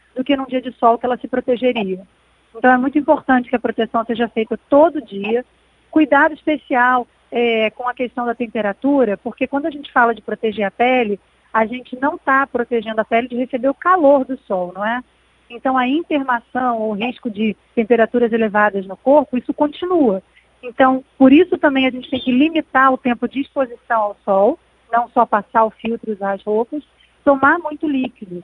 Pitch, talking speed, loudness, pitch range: 245 Hz, 195 wpm, -17 LUFS, 225-275 Hz